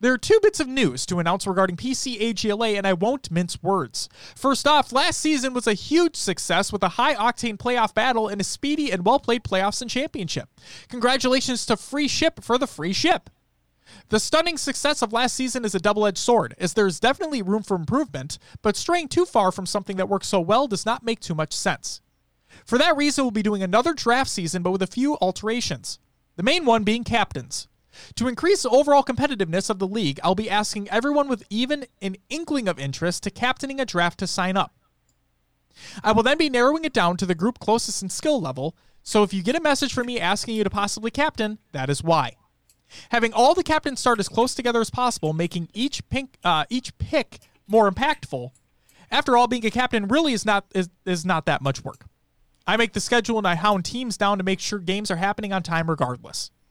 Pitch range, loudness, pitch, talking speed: 190-255 Hz, -22 LUFS, 220 Hz, 215 wpm